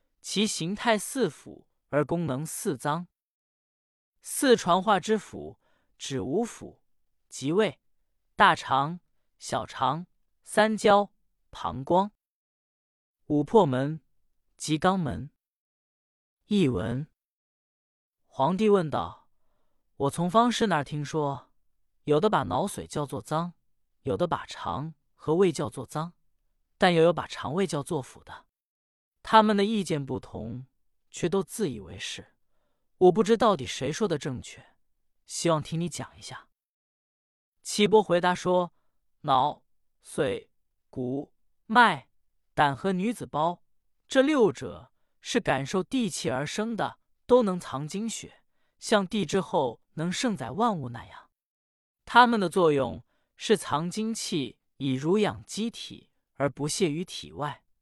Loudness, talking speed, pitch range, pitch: -27 LUFS, 175 characters per minute, 140-210 Hz, 170 Hz